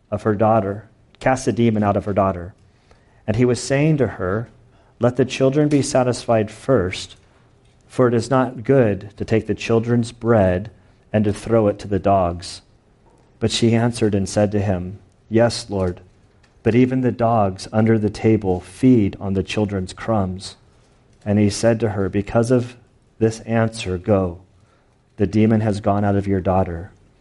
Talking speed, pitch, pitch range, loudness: 170 wpm, 110 Hz, 100-120 Hz, -19 LUFS